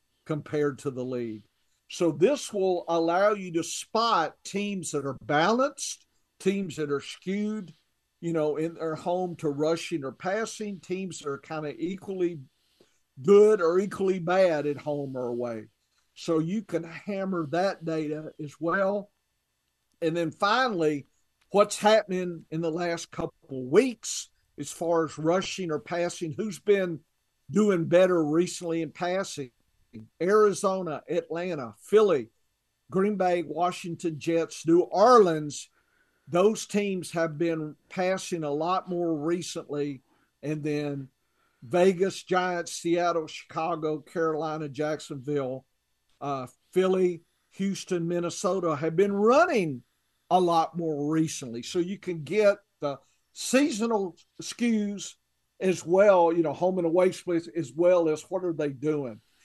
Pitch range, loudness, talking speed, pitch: 150-190 Hz, -27 LUFS, 135 wpm, 170 Hz